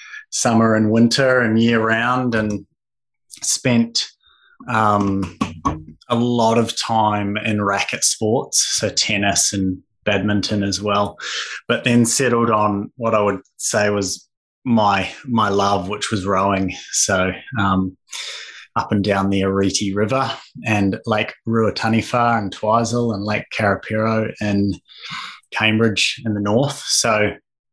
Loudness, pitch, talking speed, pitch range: -18 LUFS, 105 Hz, 130 wpm, 100-115 Hz